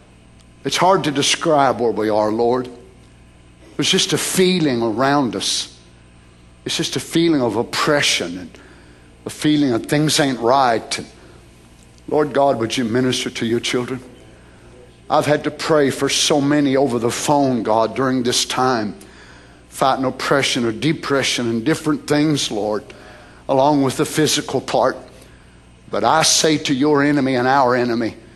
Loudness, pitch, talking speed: -17 LUFS, 125 Hz, 150 wpm